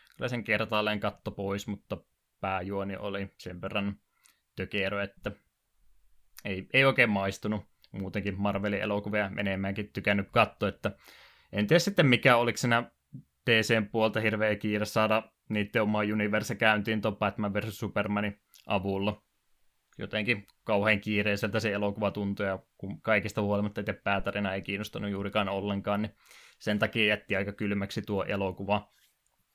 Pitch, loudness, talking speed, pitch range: 105 Hz, -29 LUFS, 130 wpm, 100-110 Hz